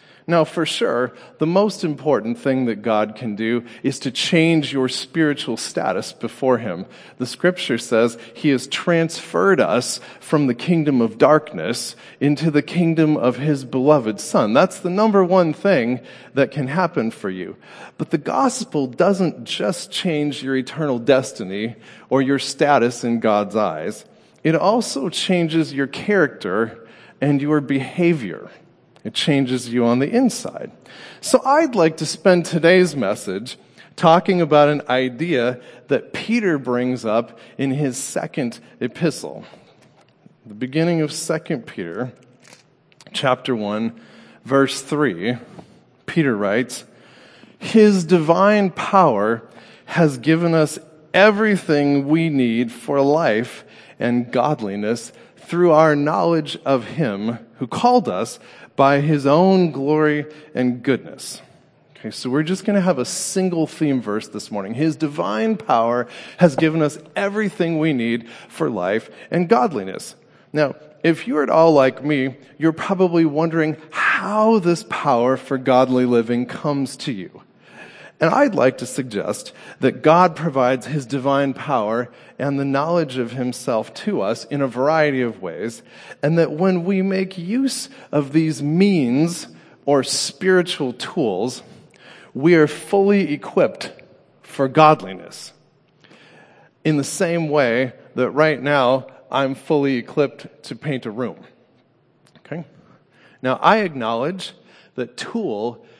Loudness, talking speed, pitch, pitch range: -19 LUFS, 135 wpm, 150 Hz, 130-170 Hz